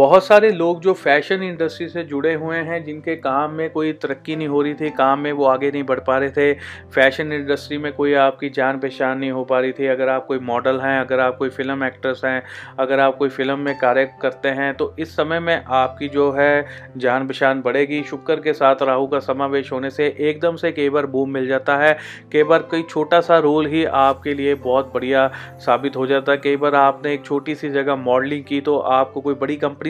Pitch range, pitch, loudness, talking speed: 135-150 Hz, 140 Hz, -19 LUFS, 230 wpm